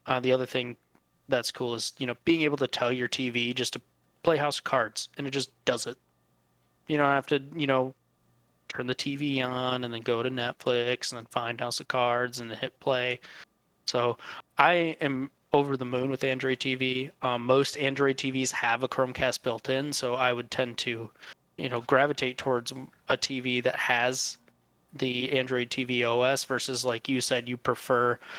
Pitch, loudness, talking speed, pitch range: 130 Hz, -28 LUFS, 195 wpm, 120-135 Hz